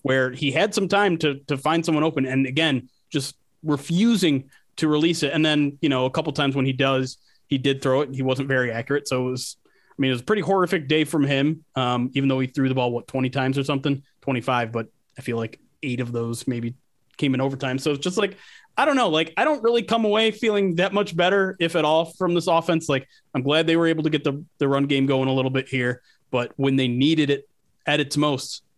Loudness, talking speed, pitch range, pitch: -22 LUFS, 255 wpm, 130-160 Hz, 140 Hz